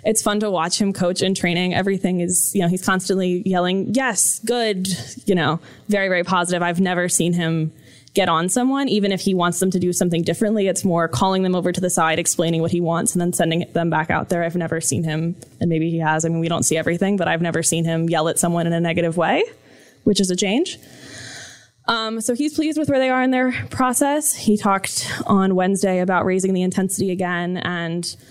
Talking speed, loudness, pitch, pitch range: 230 wpm, -19 LUFS, 180 Hz, 170-200 Hz